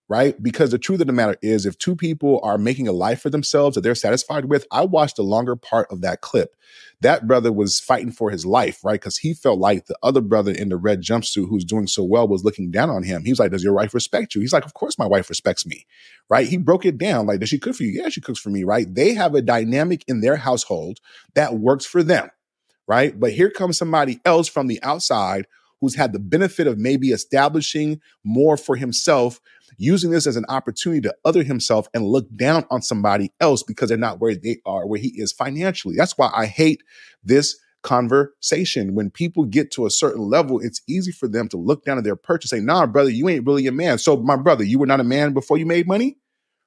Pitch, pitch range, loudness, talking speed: 135 Hz, 110-160 Hz, -19 LUFS, 240 wpm